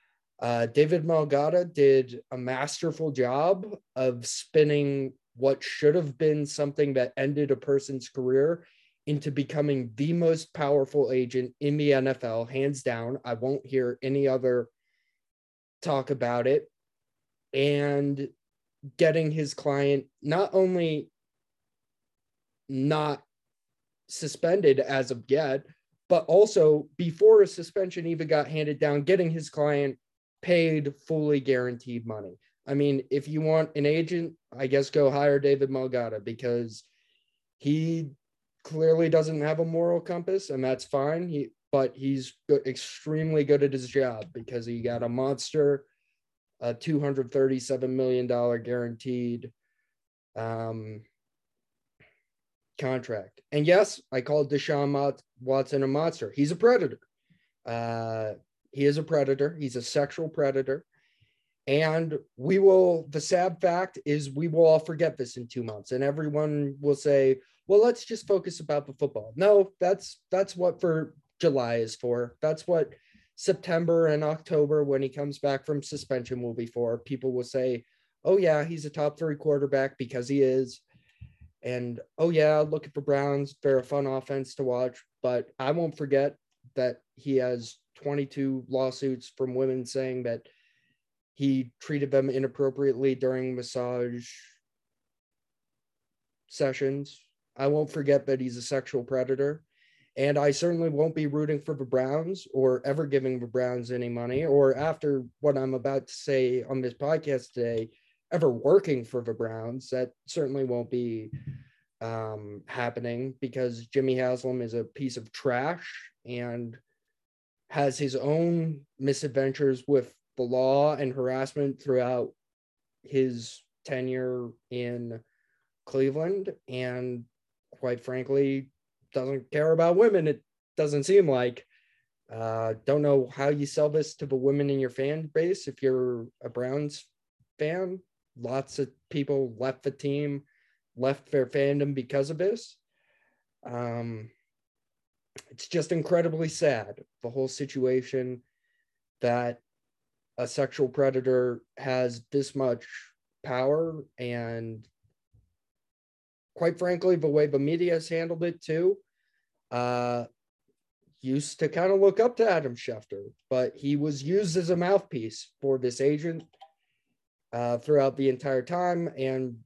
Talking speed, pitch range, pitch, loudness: 135 wpm, 125-150 Hz, 140 Hz, -27 LUFS